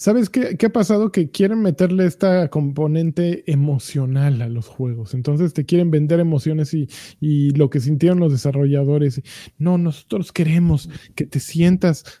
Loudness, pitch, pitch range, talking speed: -18 LUFS, 155 Hz, 140-175 Hz, 155 wpm